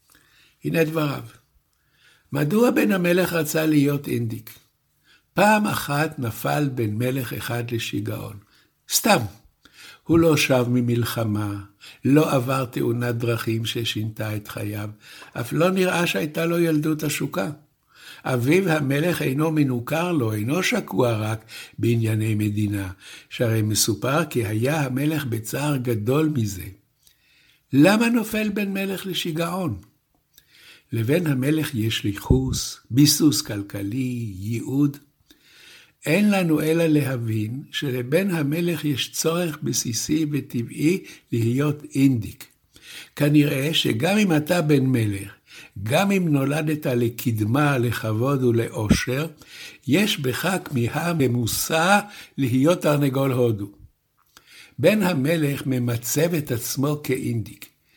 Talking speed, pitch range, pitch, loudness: 105 wpm, 115-155 Hz, 135 Hz, -22 LUFS